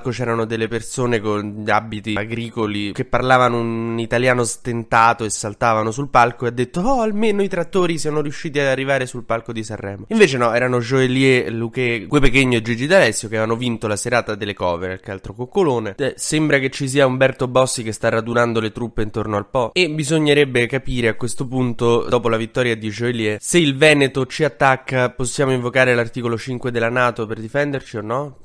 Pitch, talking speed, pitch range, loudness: 120 Hz, 190 wpm, 115-135 Hz, -18 LUFS